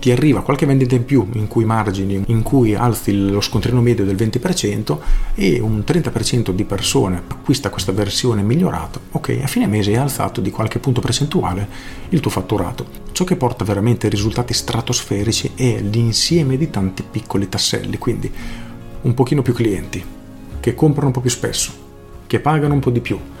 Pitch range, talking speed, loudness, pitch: 100-125 Hz, 175 wpm, -18 LUFS, 115 Hz